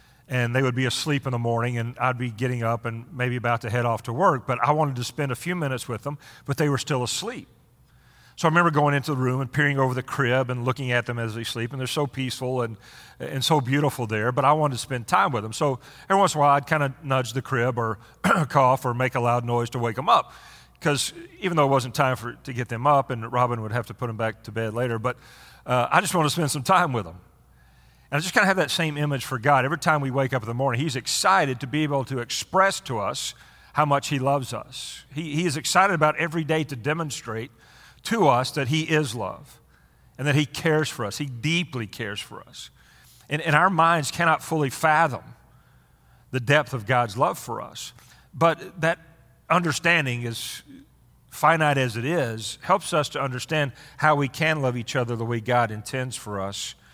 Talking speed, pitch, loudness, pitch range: 235 wpm, 130 Hz, -24 LUFS, 120-150 Hz